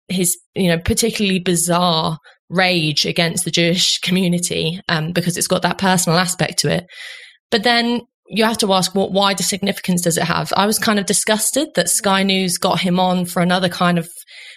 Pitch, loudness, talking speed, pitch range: 185 Hz, -17 LUFS, 200 wpm, 175-200 Hz